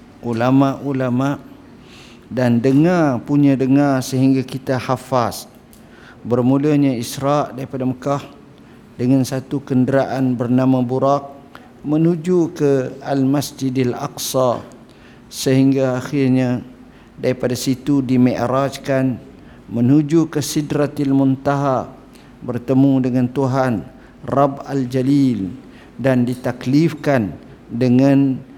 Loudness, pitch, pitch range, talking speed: -18 LUFS, 135 Hz, 125-140 Hz, 80 wpm